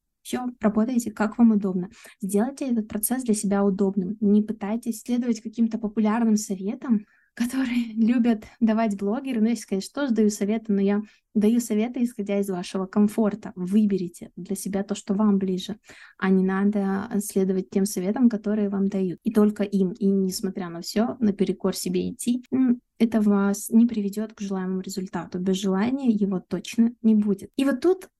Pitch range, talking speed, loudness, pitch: 195-225 Hz, 165 wpm, -24 LUFS, 210 Hz